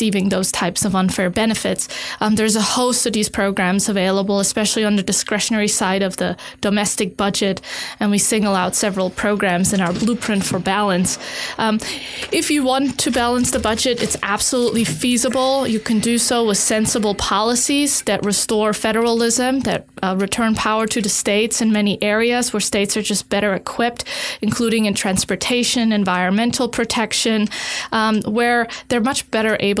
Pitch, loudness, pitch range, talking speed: 215 Hz, -18 LUFS, 200-235 Hz, 165 wpm